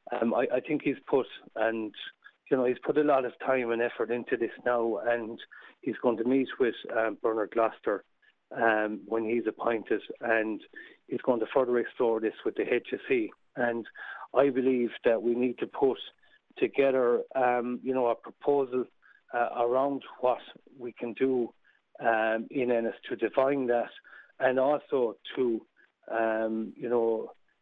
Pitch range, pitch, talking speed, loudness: 115-140 Hz, 120 Hz, 165 wpm, -29 LUFS